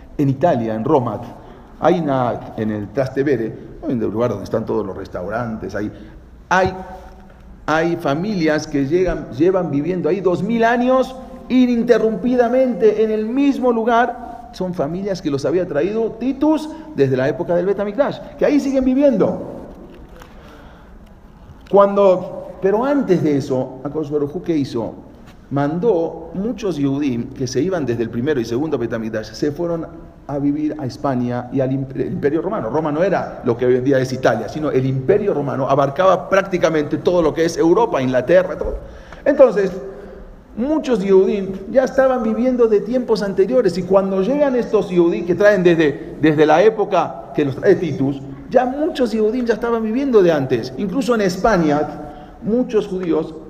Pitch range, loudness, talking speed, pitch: 145-230 Hz, -18 LUFS, 155 wpm, 185 Hz